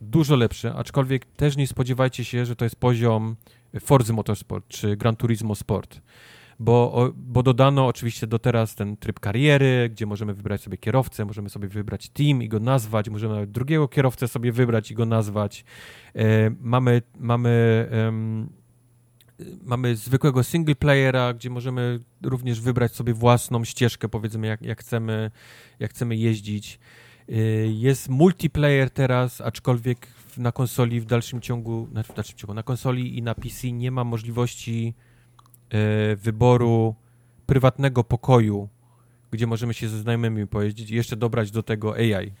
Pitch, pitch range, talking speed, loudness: 120 Hz, 110-125 Hz, 140 wpm, -23 LUFS